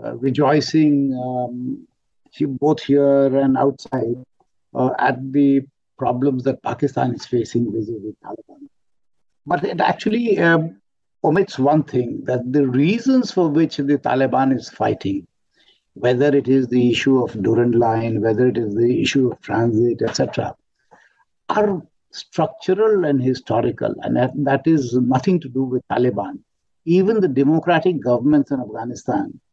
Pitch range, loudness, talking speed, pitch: 125-155 Hz, -19 LUFS, 140 wpm, 135 Hz